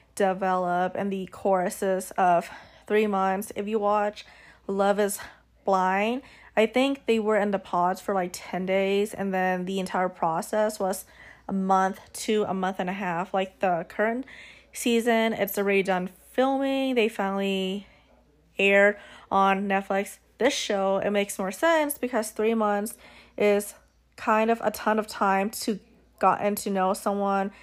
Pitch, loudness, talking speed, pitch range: 200 Hz, -26 LUFS, 155 wpm, 190-215 Hz